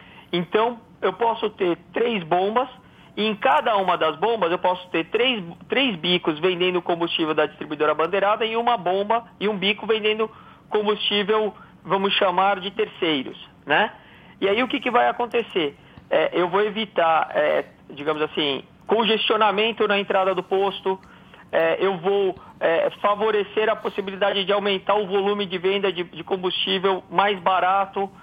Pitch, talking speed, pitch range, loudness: 200 Hz, 155 wpm, 180-215 Hz, -22 LUFS